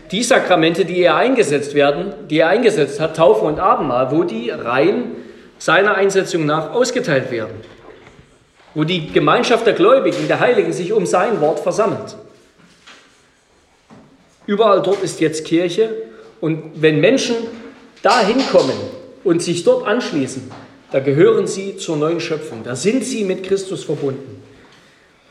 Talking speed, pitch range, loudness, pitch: 140 wpm, 155-205 Hz, -16 LUFS, 175 Hz